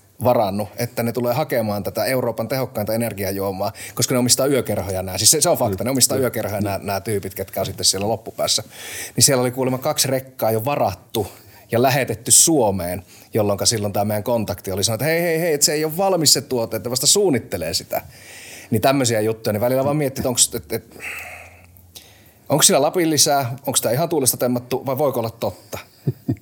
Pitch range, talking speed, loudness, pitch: 100-130 Hz, 200 wpm, -19 LUFS, 115 Hz